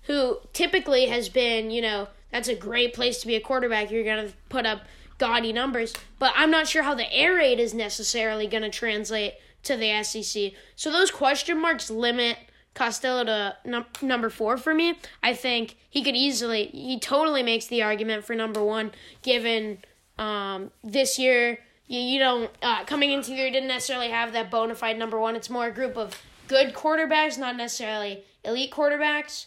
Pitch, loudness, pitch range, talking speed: 240 Hz, -25 LUFS, 220-265 Hz, 185 wpm